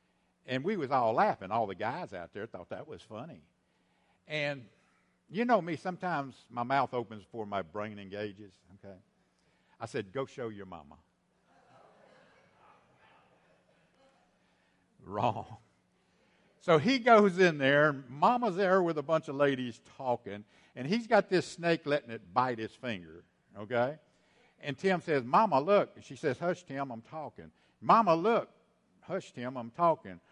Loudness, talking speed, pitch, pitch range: -31 LUFS, 150 wpm, 135 Hz, 110-170 Hz